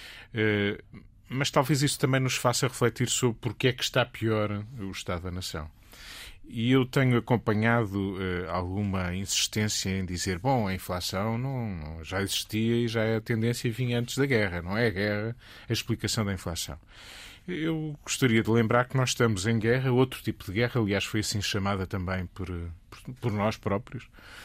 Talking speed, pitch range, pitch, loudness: 175 wpm, 100-125 Hz, 110 Hz, -28 LUFS